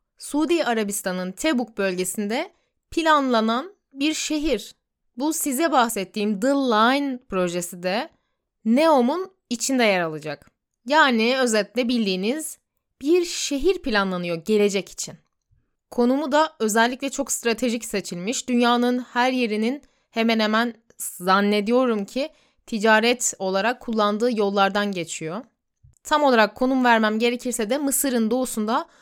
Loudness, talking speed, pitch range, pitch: -22 LUFS, 110 wpm, 210-275 Hz, 240 Hz